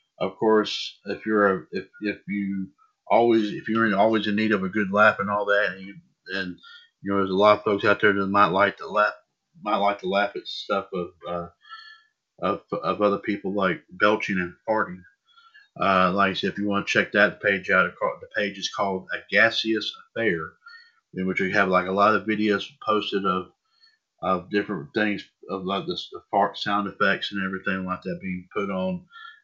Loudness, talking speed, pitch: -24 LUFS, 210 wpm, 105 Hz